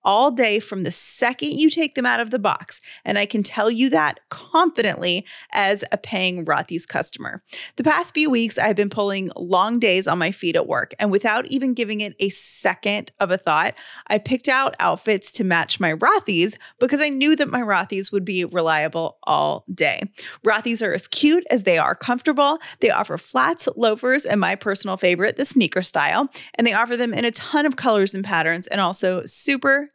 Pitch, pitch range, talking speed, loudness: 215 Hz, 190-260 Hz, 200 wpm, -20 LUFS